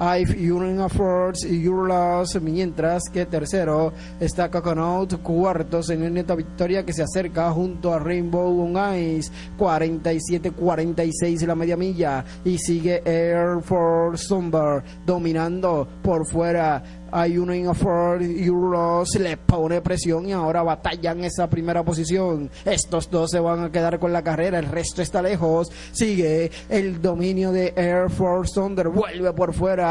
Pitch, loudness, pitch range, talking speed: 175 Hz, -22 LUFS, 165-180 Hz, 145 wpm